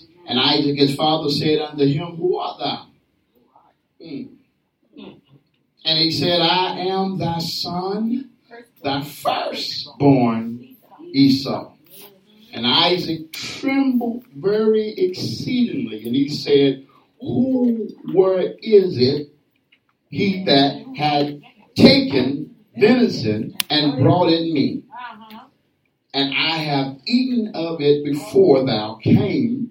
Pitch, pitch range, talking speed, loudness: 165 Hz, 140-225 Hz, 100 wpm, -19 LUFS